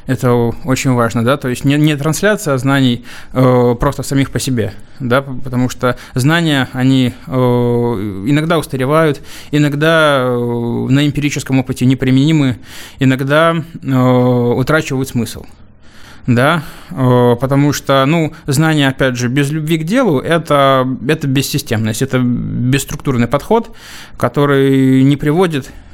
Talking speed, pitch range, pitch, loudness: 125 wpm, 125-145 Hz, 135 Hz, -13 LUFS